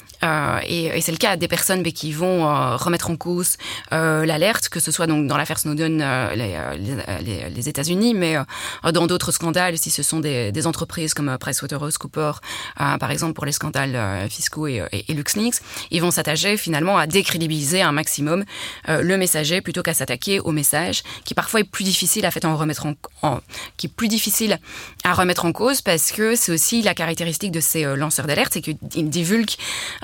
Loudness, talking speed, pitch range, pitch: -20 LUFS, 205 wpm, 150-180 Hz, 160 Hz